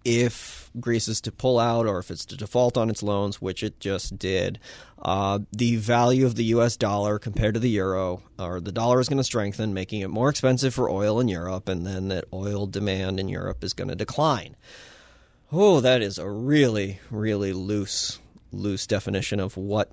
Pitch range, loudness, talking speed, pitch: 95-120 Hz, -25 LUFS, 200 wpm, 105 Hz